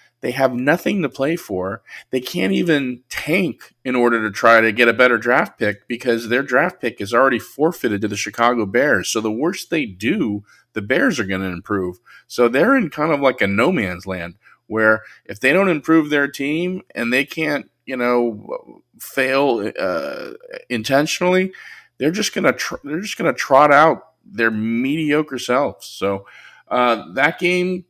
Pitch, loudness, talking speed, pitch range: 125 Hz, -18 LUFS, 185 wpm, 115-155 Hz